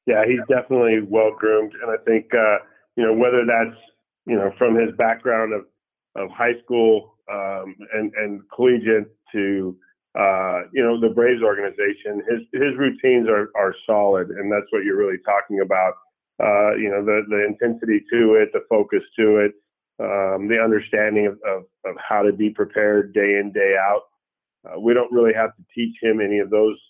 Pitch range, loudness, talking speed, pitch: 100-115 Hz, -20 LUFS, 185 wpm, 110 Hz